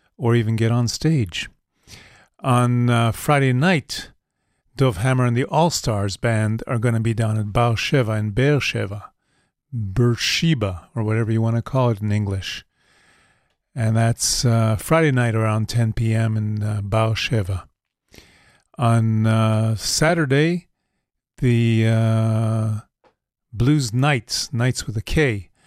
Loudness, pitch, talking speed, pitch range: -20 LUFS, 115 Hz, 135 wpm, 110-125 Hz